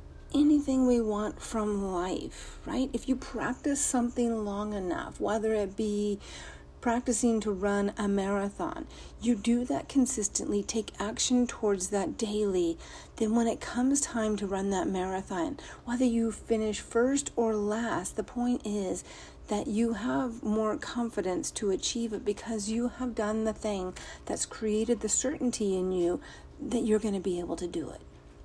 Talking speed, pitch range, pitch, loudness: 160 wpm, 205-245 Hz, 220 Hz, -30 LUFS